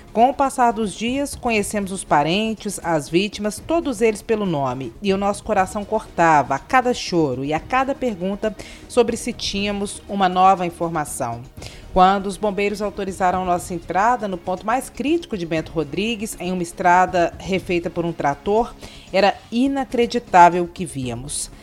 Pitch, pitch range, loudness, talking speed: 195 Hz, 175-225 Hz, -20 LUFS, 160 wpm